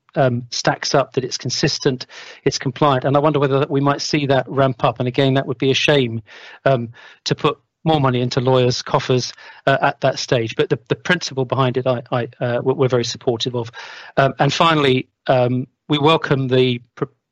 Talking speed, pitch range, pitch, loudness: 205 wpm, 125-145 Hz, 135 Hz, -18 LUFS